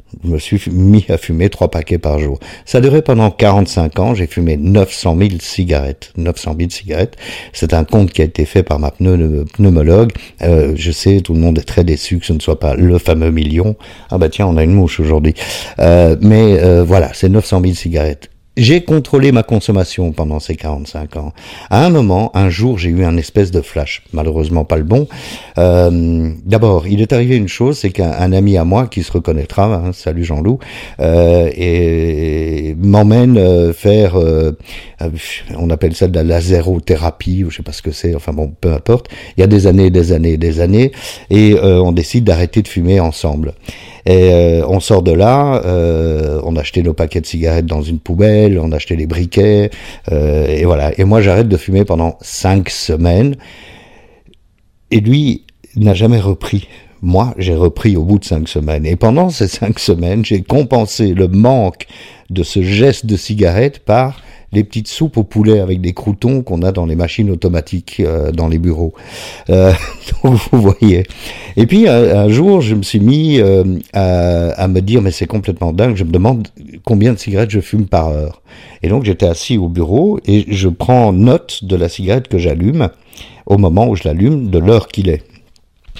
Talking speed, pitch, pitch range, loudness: 200 wpm, 95 Hz, 85-105 Hz, -12 LUFS